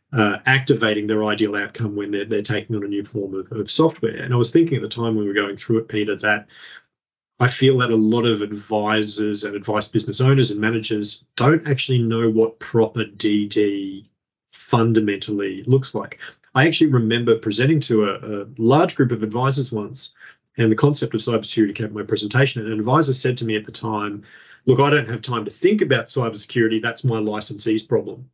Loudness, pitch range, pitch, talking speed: -19 LUFS, 105-125 Hz, 110 Hz, 205 wpm